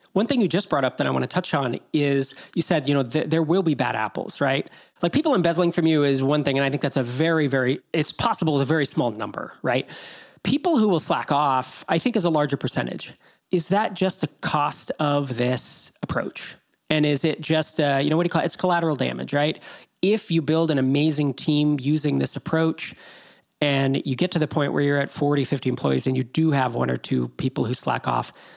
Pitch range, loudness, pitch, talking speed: 140-165 Hz, -23 LUFS, 150 Hz, 235 wpm